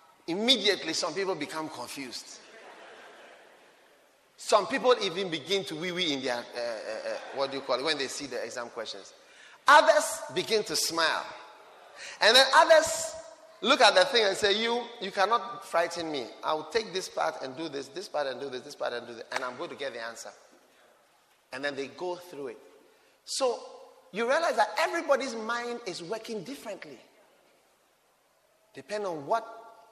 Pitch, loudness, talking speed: 225 Hz, -28 LUFS, 175 wpm